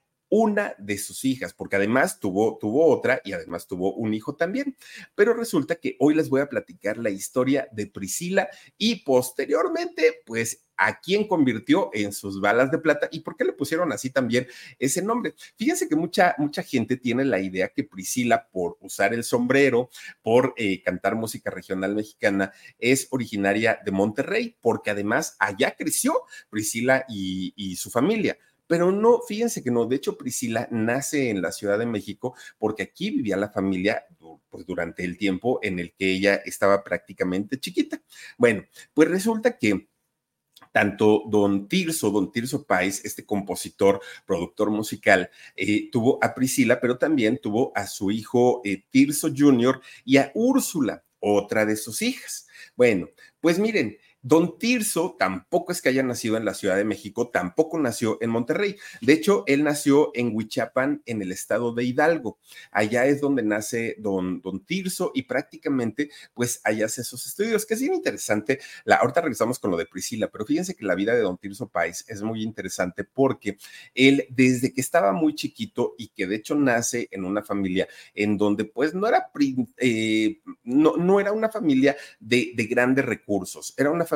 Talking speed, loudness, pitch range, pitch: 175 wpm, -24 LUFS, 105-175 Hz, 130 Hz